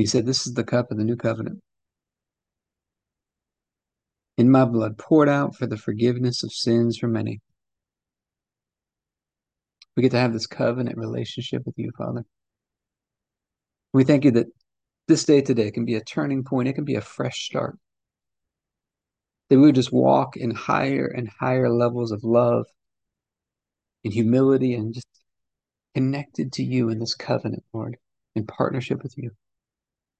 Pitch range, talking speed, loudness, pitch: 110-130 Hz, 155 wpm, -22 LUFS, 120 Hz